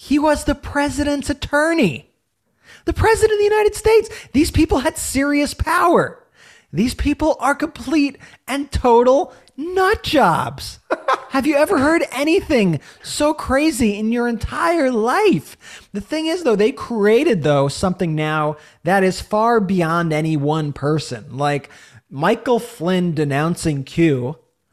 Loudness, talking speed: -18 LUFS, 135 wpm